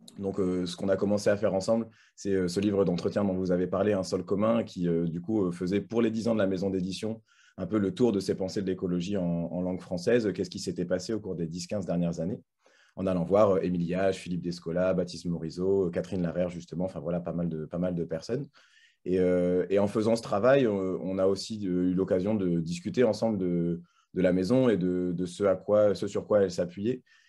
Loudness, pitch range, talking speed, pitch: -29 LUFS, 90-105 Hz, 250 wpm, 95 Hz